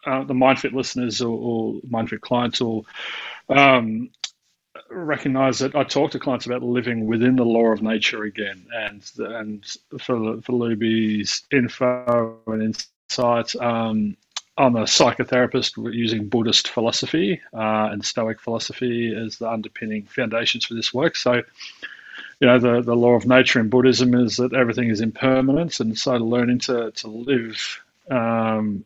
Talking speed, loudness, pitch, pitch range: 155 wpm, -21 LUFS, 120 Hz, 110-125 Hz